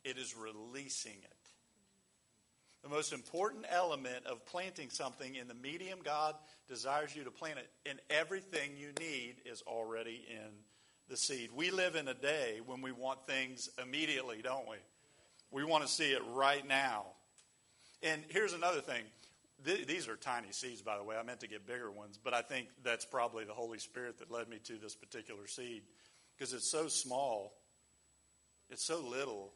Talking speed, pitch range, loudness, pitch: 175 wpm, 115-150 Hz, -40 LUFS, 130 Hz